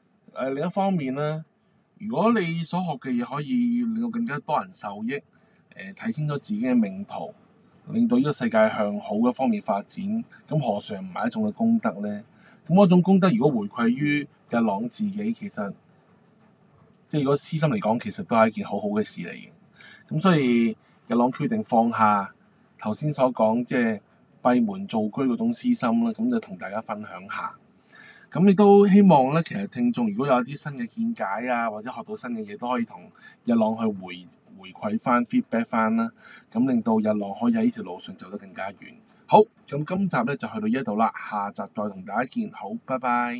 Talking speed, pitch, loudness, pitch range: 290 characters per minute, 210 Hz, -24 LUFS, 160-225 Hz